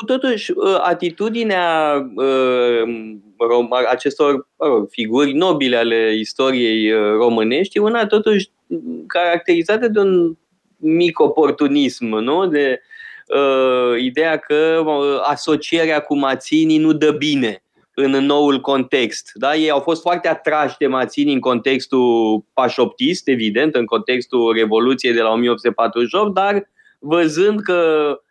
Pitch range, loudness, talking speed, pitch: 125-175 Hz, -16 LUFS, 110 wpm, 145 Hz